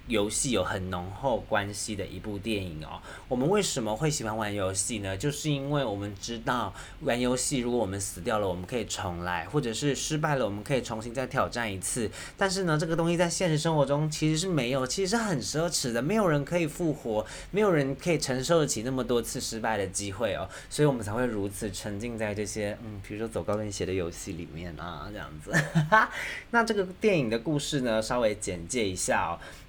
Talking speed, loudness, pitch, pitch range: 330 characters per minute, -29 LUFS, 120 Hz, 105-150 Hz